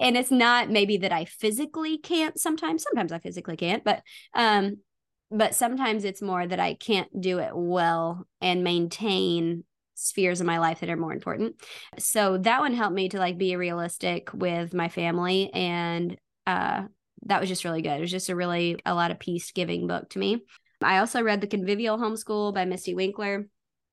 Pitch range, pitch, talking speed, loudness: 175-215 Hz, 190 Hz, 190 wpm, -26 LUFS